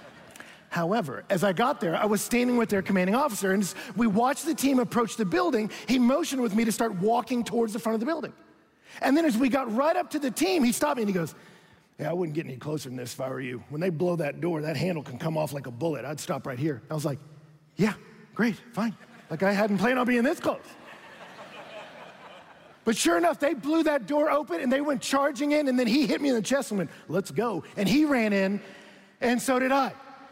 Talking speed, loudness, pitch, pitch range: 250 wpm, -27 LUFS, 225 Hz, 180-270 Hz